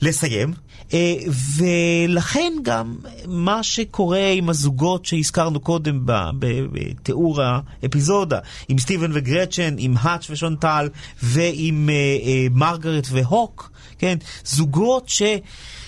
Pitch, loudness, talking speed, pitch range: 160 Hz, -20 LUFS, 90 wpm, 135-175 Hz